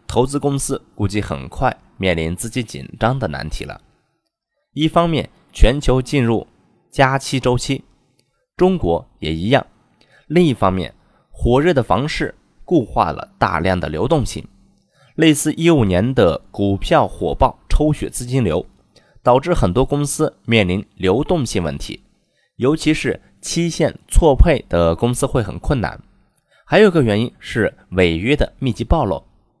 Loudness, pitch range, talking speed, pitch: -18 LUFS, 95-145 Hz, 220 characters per minute, 125 Hz